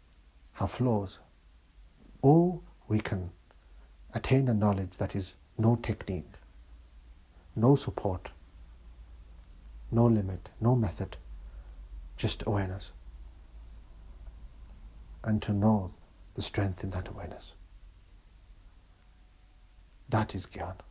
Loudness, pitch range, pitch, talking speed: -30 LUFS, 70-100 Hz, 90 Hz, 90 wpm